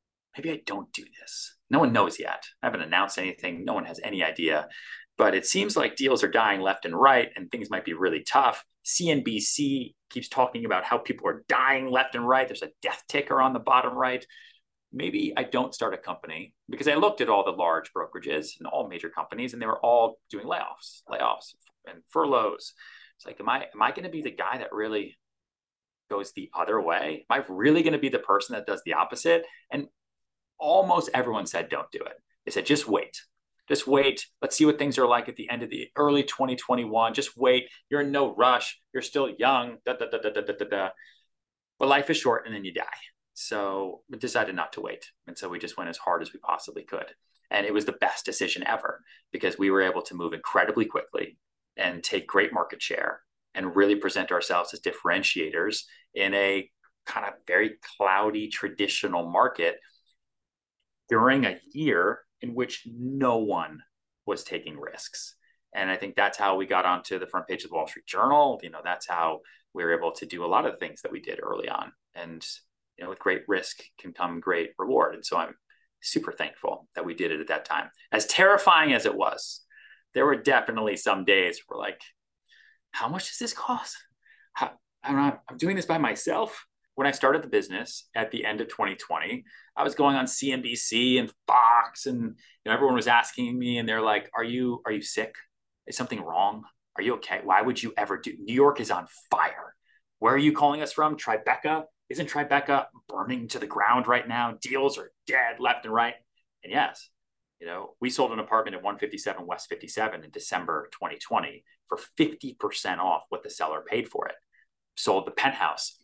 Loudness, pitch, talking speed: -26 LUFS, 140 Hz, 205 wpm